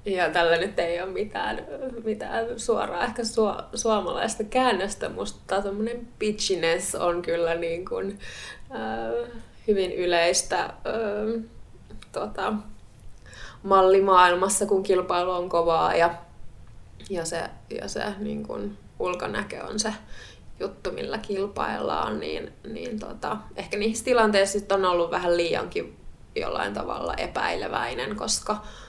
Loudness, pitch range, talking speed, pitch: -26 LUFS, 165-215 Hz, 115 wpm, 185 Hz